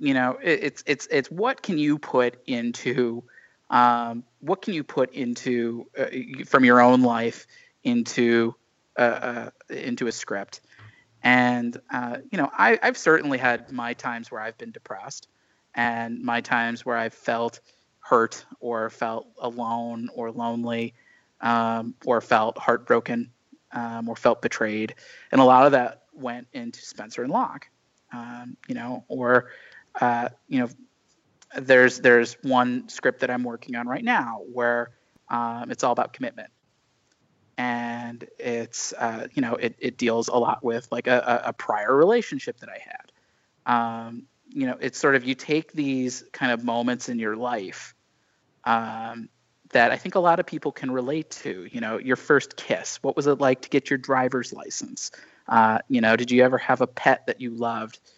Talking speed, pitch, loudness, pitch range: 170 wpm, 120 Hz, -24 LUFS, 115-130 Hz